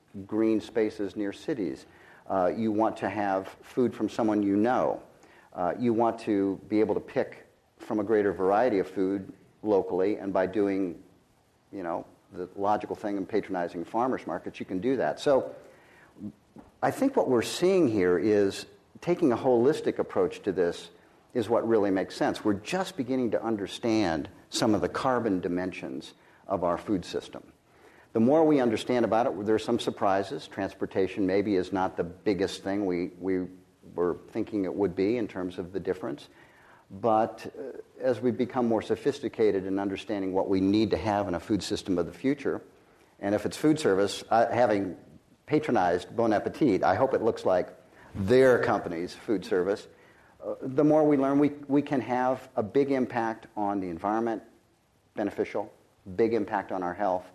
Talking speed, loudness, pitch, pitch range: 175 wpm, -28 LUFS, 105 Hz, 95-125 Hz